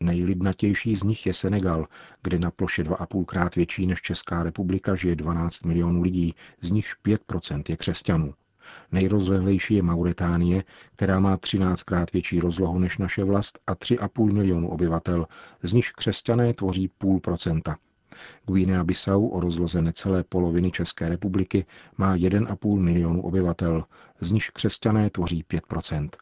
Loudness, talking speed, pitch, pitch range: -25 LUFS, 140 wpm, 90 Hz, 85-100 Hz